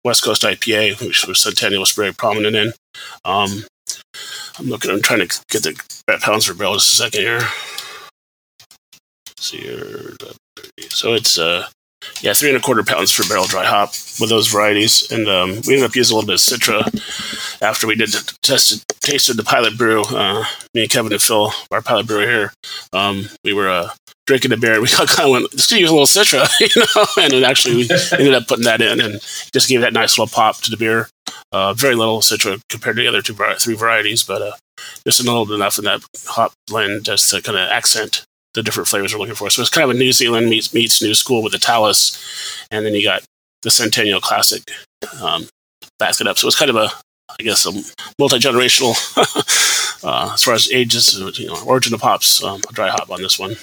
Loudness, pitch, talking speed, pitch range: -14 LUFS, 115 Hz, 215 wpm, 105-135 Hz